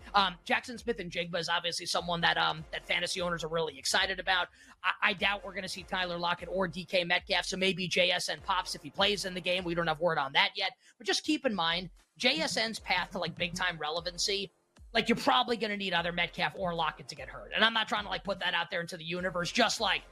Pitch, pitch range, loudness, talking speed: 180 Hz, 175-200 Hz, -30 LUFS, 255 wpm